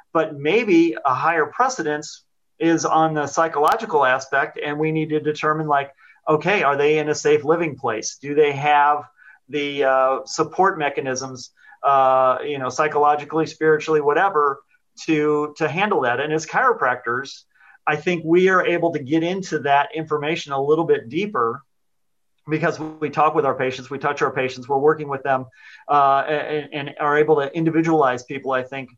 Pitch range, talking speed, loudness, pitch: 140-160 Hz, 170 wpm, -20 LUFS, 150 Hz